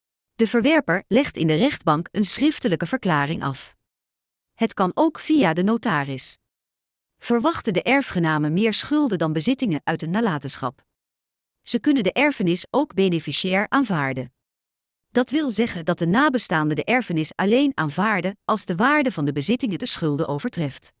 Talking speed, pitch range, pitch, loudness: 150 wpm, 150-245 Hz, 185 Hz, -22 LUFS